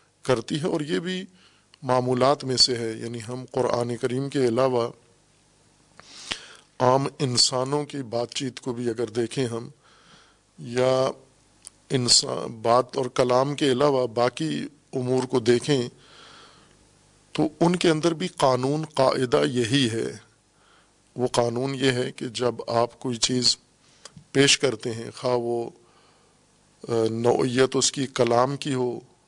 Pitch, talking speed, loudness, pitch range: 125 Hz, 135 wpm, -24 LUFS, 120-135 Hz